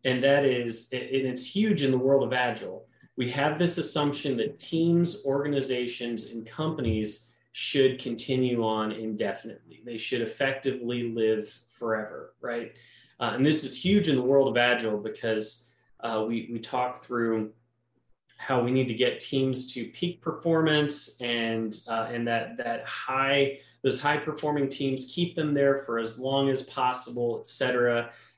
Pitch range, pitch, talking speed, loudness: 115-140 Hz, 125 Hz, 160 wpm, -28 LUFS